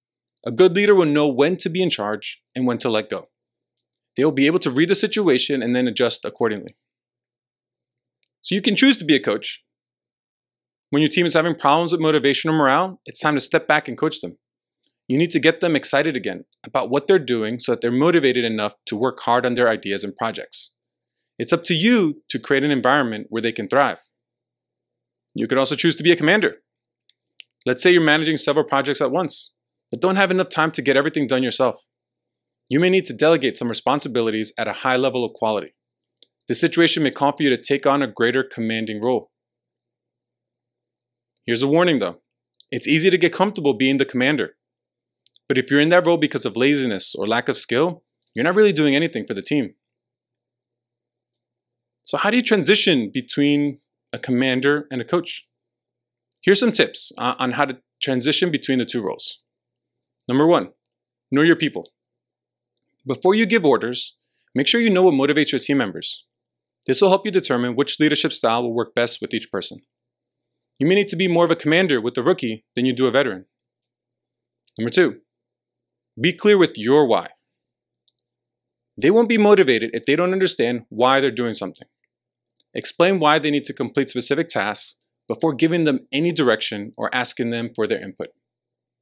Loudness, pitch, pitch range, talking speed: -19 LUFS, 140 Hz, 120-170 Hz, 190 wpm